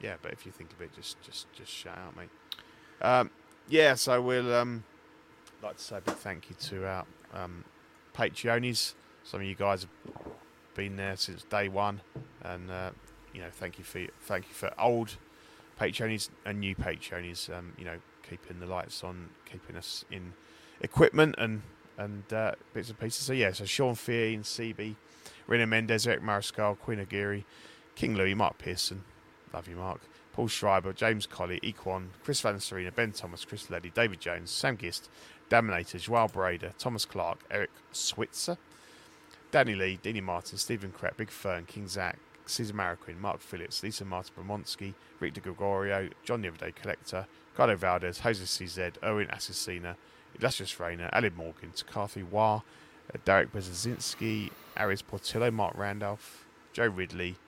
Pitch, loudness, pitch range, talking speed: 100 Hz, -32 LUFS, 90-115 Hz, 165 wpm